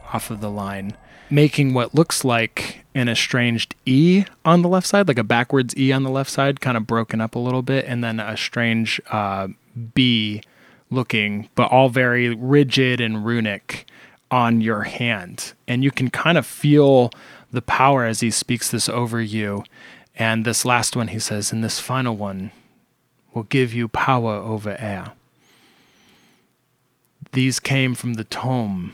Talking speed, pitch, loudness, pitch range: 170 wpm, 120 Hz, -20 LUFS, 110-130 Hz